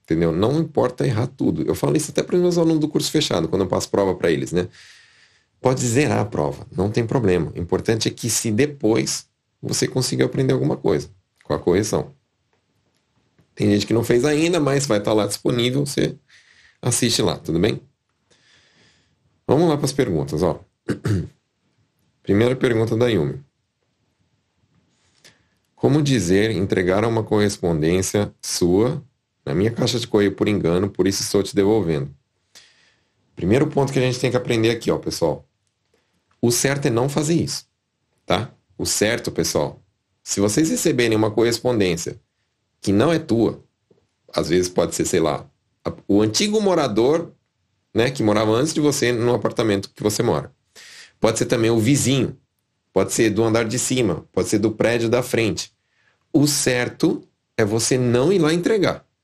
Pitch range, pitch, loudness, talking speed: 100-130 Hz, 115 Hz, -20 LUFS, 165 wpm